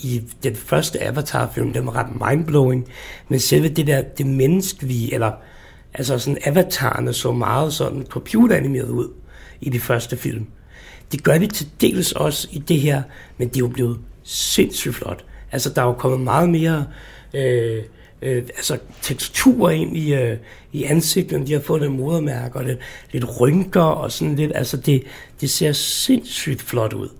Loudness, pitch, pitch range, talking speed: -20 LUFS, 130 Hz, 120-150 Hz, 180 wpm